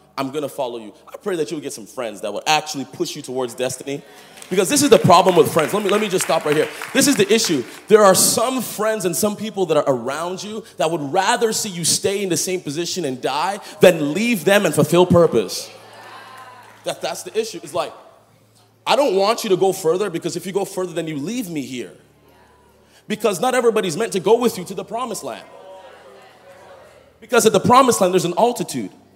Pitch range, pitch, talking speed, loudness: 165-215 Hz, 190 Hz, 225 wpm, -18 LUFS